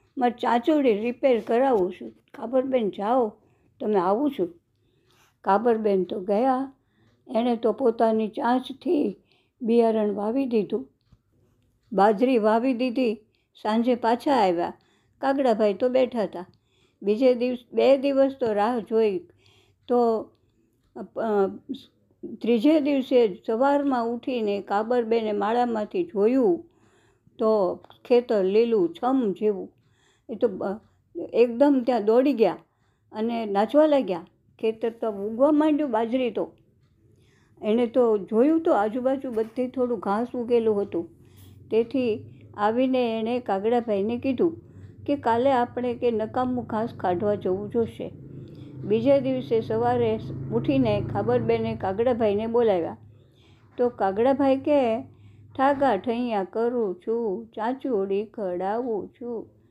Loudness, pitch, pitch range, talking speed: -24 LUFS, 225 Hz, 195-250 Hz, 110 wpm